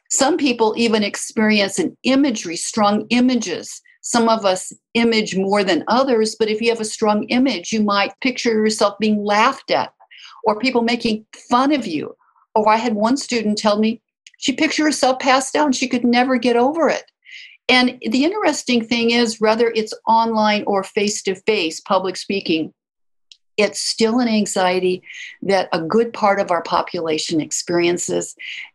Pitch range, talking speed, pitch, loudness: 205-250 Hz, 165 wpm, 225 Hz, -18 LUFS